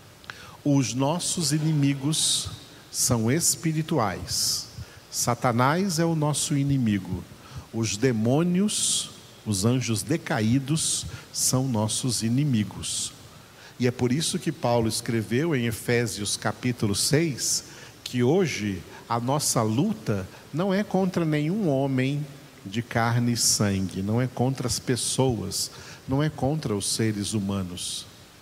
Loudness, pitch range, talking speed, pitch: -25 LUFS, 115-150 Hz, 115 wpm, 125 Hz